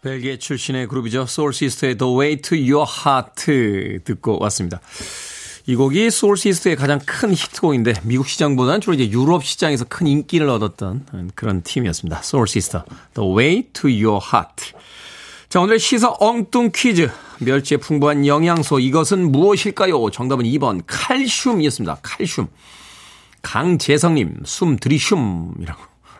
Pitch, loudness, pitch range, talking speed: 145 Hz, -17 LUFS, 125-170 Hz, 365 characters per minute